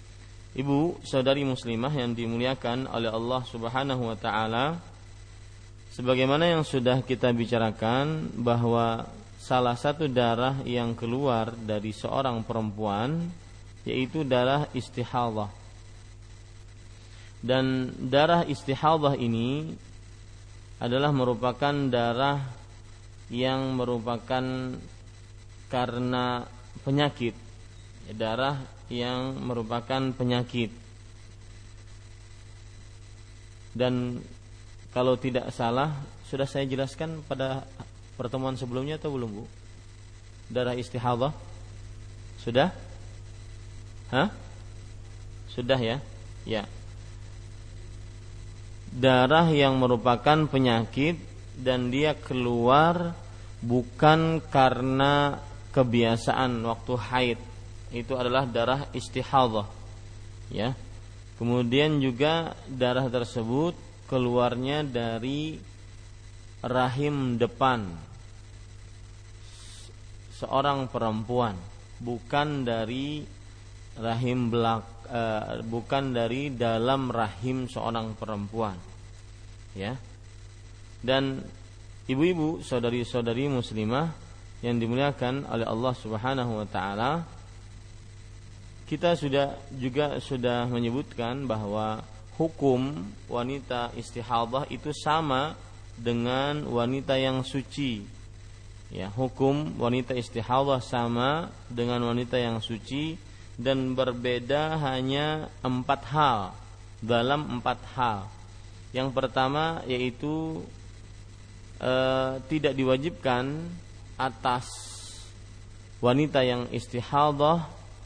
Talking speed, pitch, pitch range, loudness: 80 wpm, 120 Hz, 105-130 Hz, -28 LUFS